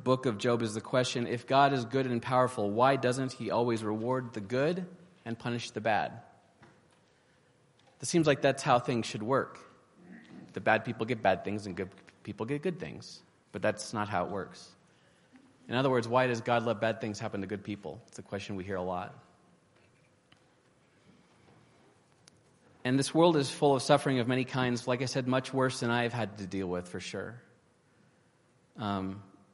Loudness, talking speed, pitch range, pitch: -31 LUFS, 190 wpm, 105-130 Hz, 120 Hz